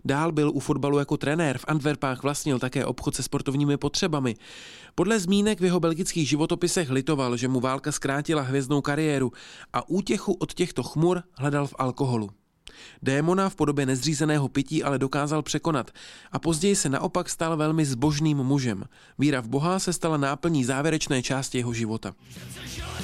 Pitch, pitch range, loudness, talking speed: 145 Hz, 130-160 Hz, -26 LUFS, 160 wpm